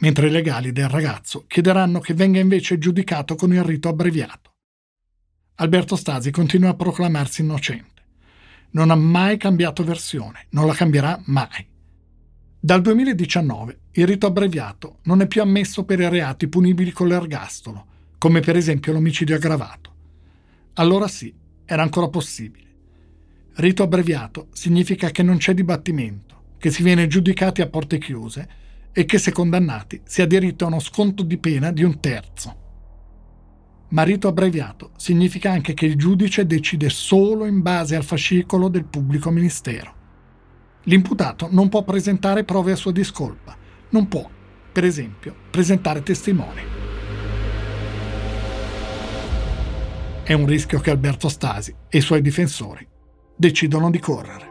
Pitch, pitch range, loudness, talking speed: 160 Hz, 105-180 Hz, -19 LUFS, 140 wpm